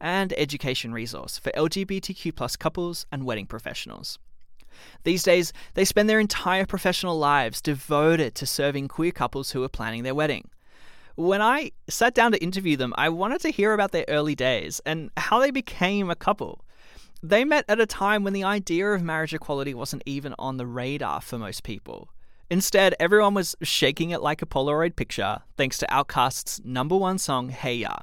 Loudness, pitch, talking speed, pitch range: -24 LUFS, 160 Hz, 180 wpm, 135-195 Hz